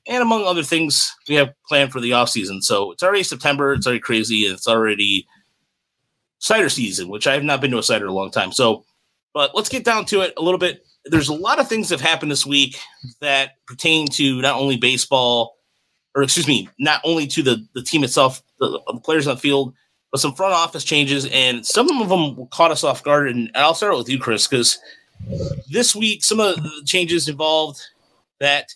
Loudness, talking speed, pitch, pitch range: -18 LUFS, 215 wpm, 145 Hz, 130-165 Hz